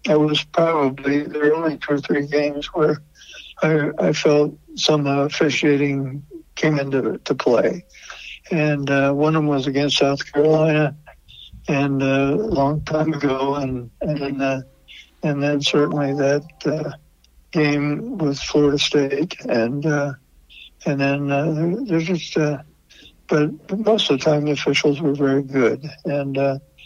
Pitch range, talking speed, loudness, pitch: 140-155 Hz, 150 wpm, -20 LUFS, 145 Hz